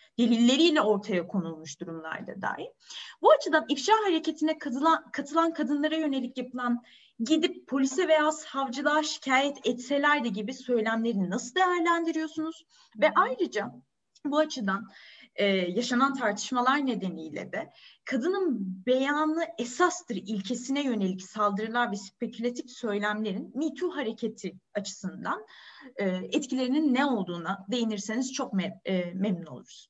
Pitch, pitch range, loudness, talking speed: 250 Hz, 210-305 Hz, -28 LUFS, 110 wpm